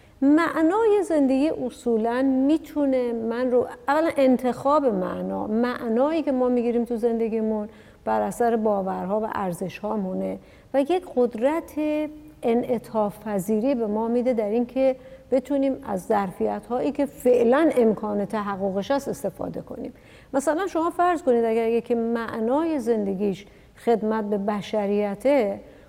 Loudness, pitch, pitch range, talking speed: -24 LUFS, 240 Hz, 215-275 Hz, 115 wpm